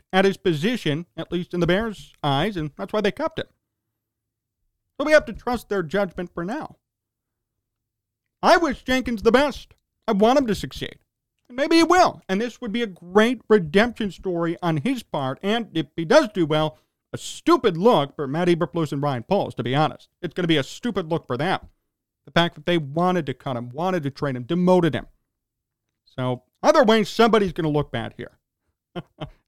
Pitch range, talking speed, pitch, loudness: 140-220 Hz, 200 wpm, 175 Hz, -22 LUFS